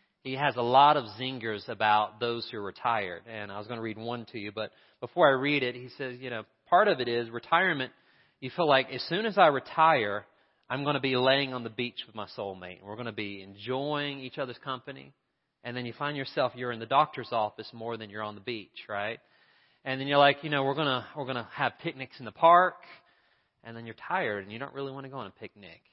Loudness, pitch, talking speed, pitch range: -29 LUFS, 125 Hz, 245 wpm, 110-140 Hz